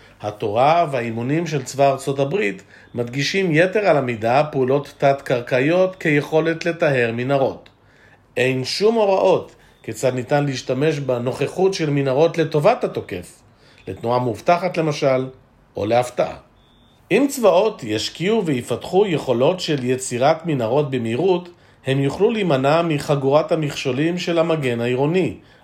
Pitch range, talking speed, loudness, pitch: 125-165 Hz, 110 wpm, -19 LUFS, 140 Hz